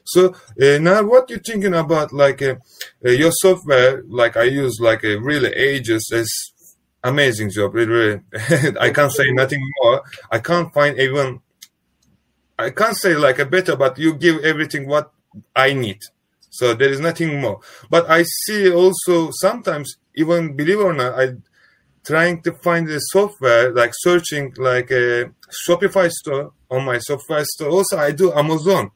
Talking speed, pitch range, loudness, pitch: 170 wpm, 130-170 Hz, -17 LUFS, 145 Hz